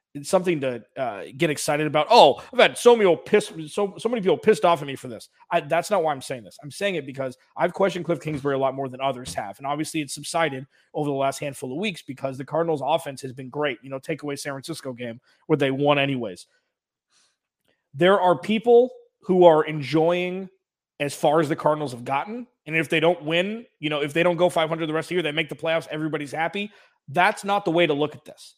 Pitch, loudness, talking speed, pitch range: 155 Hz, -23 LUFS, 245 wpm, 140-180 Hz